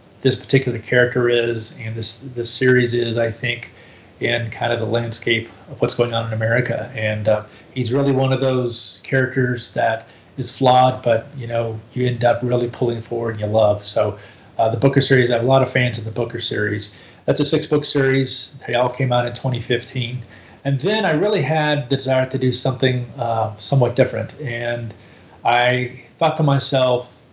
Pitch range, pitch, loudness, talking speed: 115-130 Hz, 120 Hz, -18 LUFS, 195 wpm